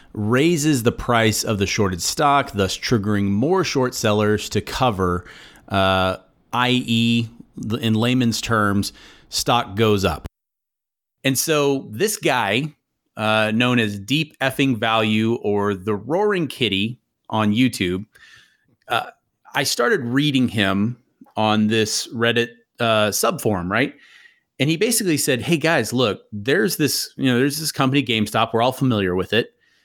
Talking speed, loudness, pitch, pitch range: 140 wpm, -20 LUFS, 115 Hz, 105-130 Hz